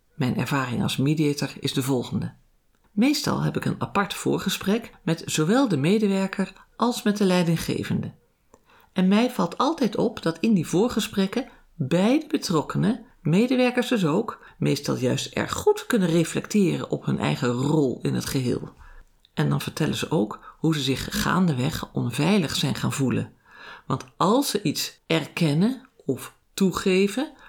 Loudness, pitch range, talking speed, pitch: -24 LUFS, 150-230 Hz, 150 wpm, 190 Hz